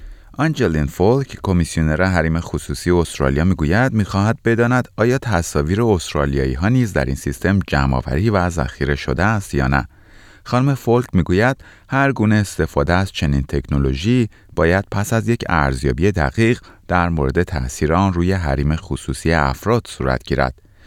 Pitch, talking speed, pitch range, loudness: 90 Hz, 145 wpm, 70-105 Hz, -18 LUFS